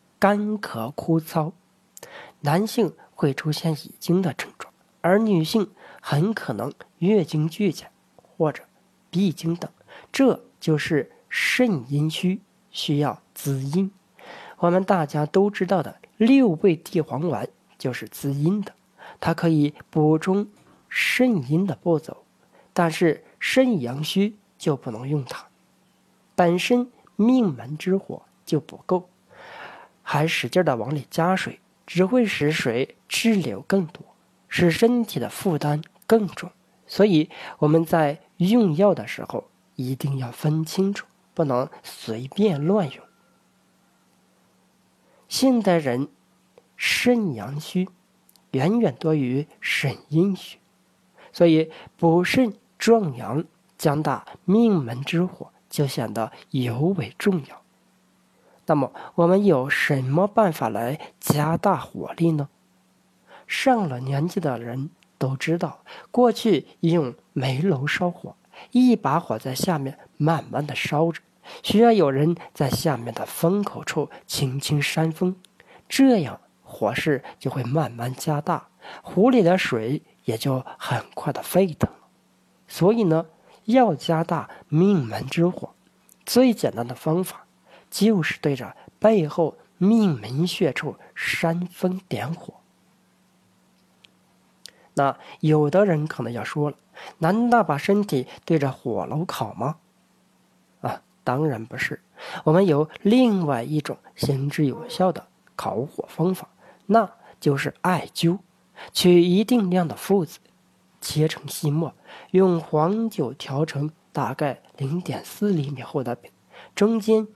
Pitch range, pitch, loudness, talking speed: 145-195 Hz, 165 Hz, -23 LUFS, 175 characters per minute